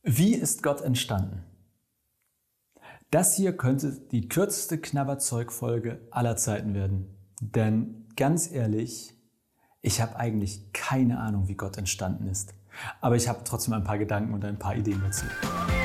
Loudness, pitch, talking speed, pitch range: -28 LUFS, 115 Hz, 140 wpm, 100-130 Hz